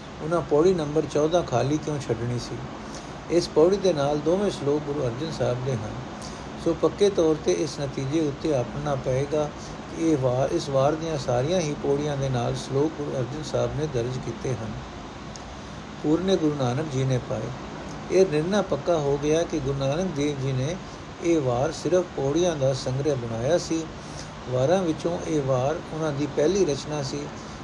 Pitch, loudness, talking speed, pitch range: 150 Hz, -25 LUFS, 175 wpm, 130-165 Hz